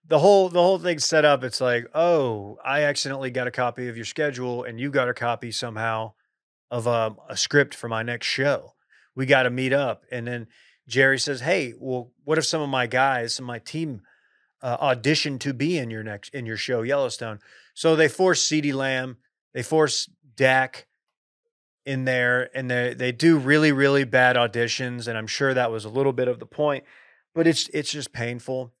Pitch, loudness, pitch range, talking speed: 130 Hz, -23 LUFS, 120-145 Hz, 200 wpm